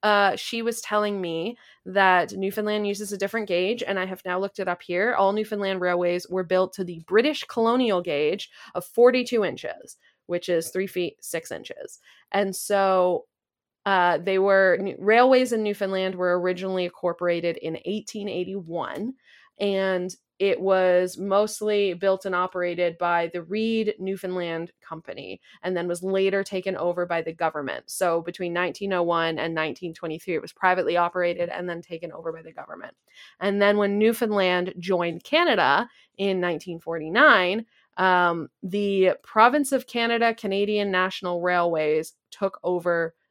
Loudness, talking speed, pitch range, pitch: -24 LUFS, 145 wpm, 175-205 Hz, 185 Hz